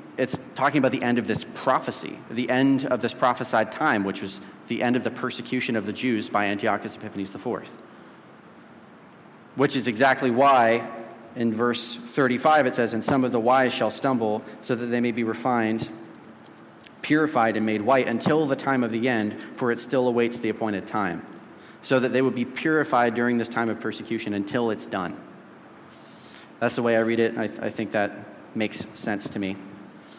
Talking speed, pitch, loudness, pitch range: 195 wpm, 120 Hz, -24 LUFS, 110-130 Hz